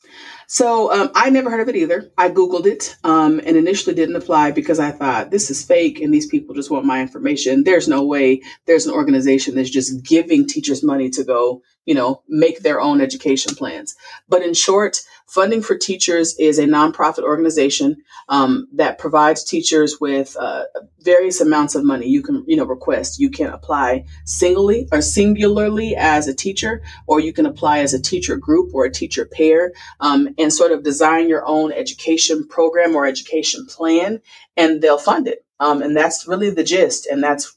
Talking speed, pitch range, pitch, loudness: 190 wpm, 150-220 Hz, 165 Hz, -16 LUFS